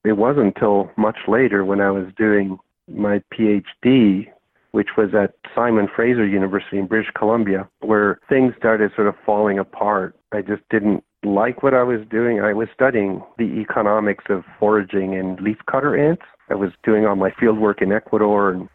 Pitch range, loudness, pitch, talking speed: 100-110 Hz, -19 LUFS, 105 Hz, 175 wpm